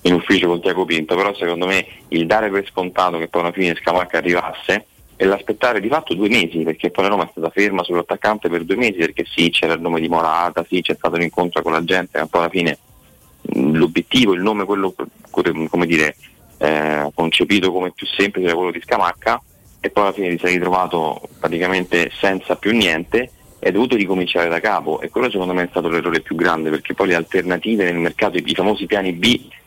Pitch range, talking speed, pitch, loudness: 85-95 Hz, 210 wpm, 90 Hz, -18 LUFS